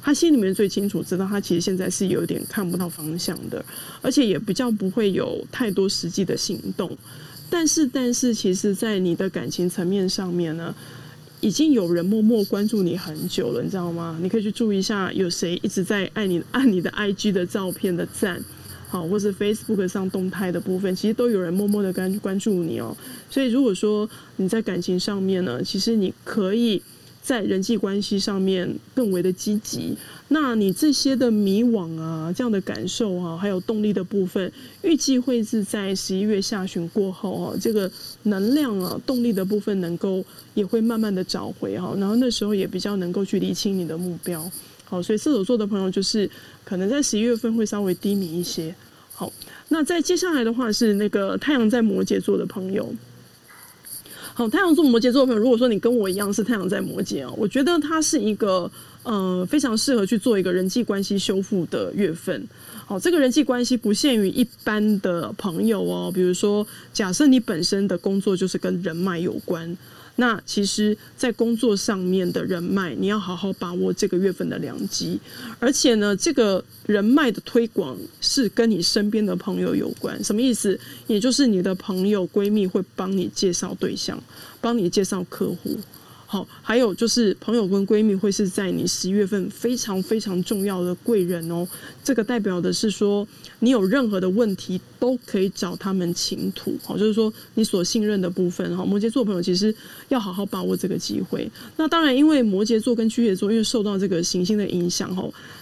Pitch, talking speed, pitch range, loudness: 205 Hz, 300 characters per minute, 185-230 Hz, -22 LUFS